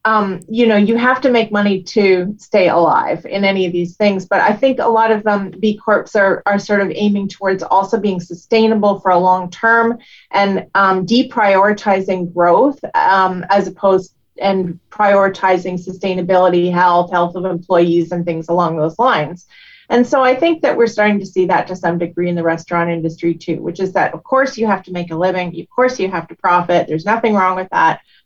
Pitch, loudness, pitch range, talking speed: 195 Hz, -15 LUFS, 180-215 Hz, 205 wpm